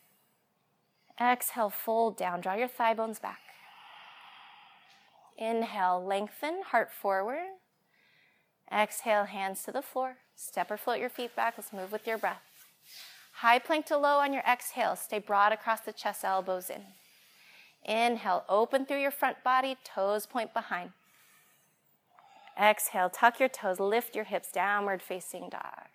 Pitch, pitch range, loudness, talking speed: 225 Hz, 200-255 Hz, -31 LUFS, 140 wpm